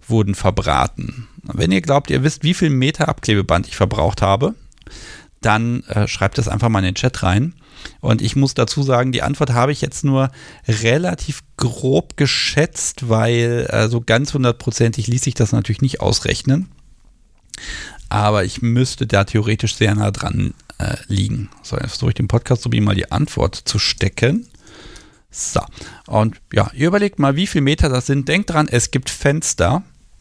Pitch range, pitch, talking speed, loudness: 110-140 Hz, 120 Hz, 175 wpm, -18 LUFS